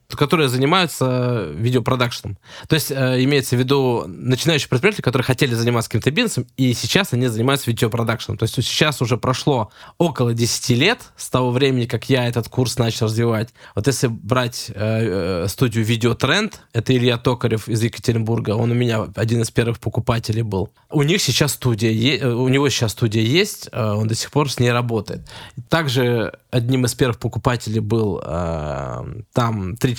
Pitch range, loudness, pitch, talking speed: 115-130 Hz, -19 LUFS, 120 Hz, 170 wpm